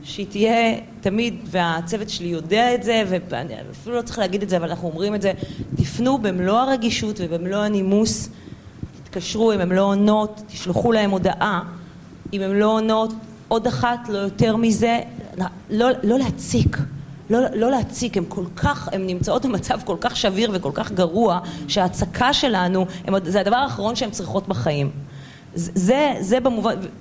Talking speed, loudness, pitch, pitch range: 160 wpm, -21 LUFS, 200 Hz, 180-225 Hz